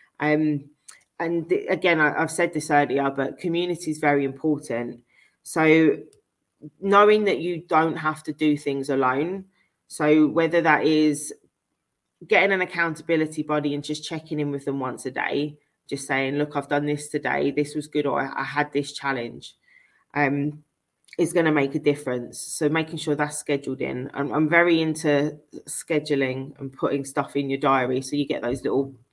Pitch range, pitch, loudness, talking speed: 140-155 Hz, 150 Hz, -23 LUFS, 175 wpm